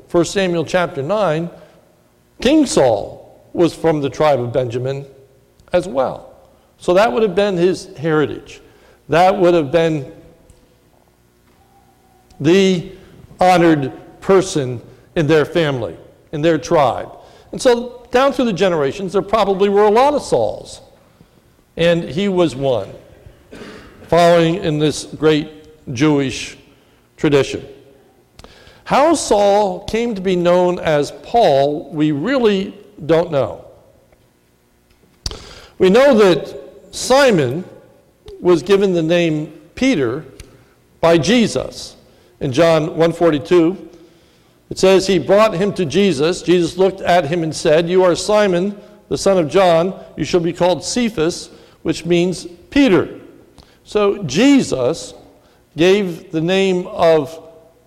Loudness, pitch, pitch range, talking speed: -15 LUFS, 170 Hz, 155-190 Hz, 120 wpm